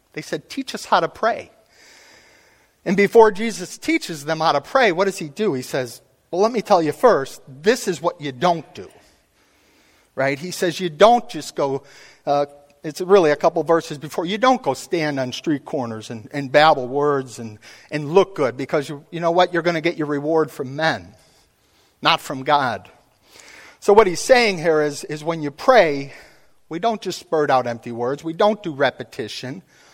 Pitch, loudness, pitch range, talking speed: 160 Hz, -20 LUFS, 145-185 Hz, 200 wpm